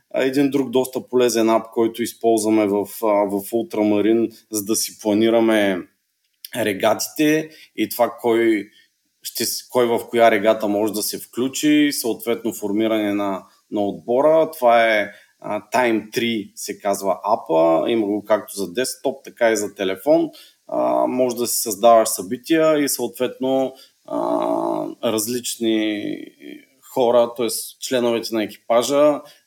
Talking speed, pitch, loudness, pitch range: 125 wpm, 115 Hz, -20 LUFS, 110-130 Hz